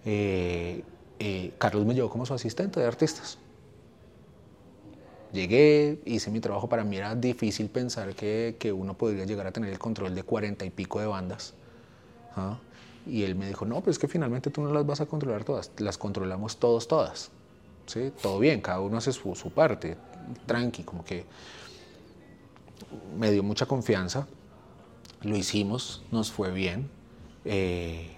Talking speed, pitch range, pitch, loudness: 165 wpm, 95-120 Hz, 110 Hz, -29 LUFS